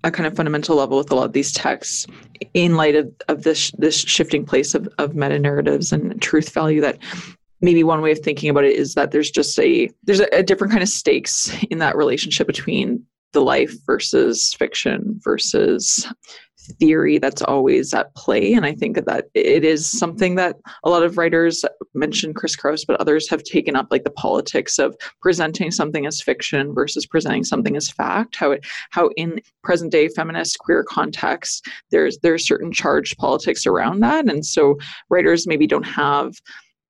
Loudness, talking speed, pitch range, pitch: -18 LUFS, 185 wpm, 150-200 Hz, 165 Hz